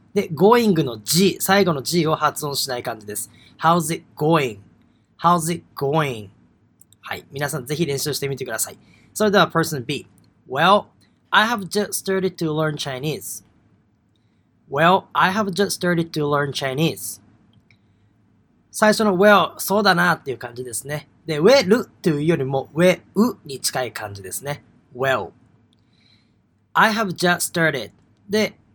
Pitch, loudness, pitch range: 150 Hz, -20 LUFS, 125-180 Hz